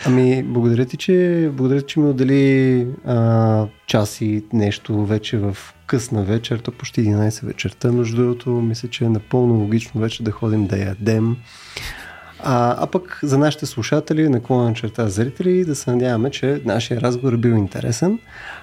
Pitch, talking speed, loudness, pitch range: 120 Hz, 160 wpm, -19 LUFS, 110-135 Hz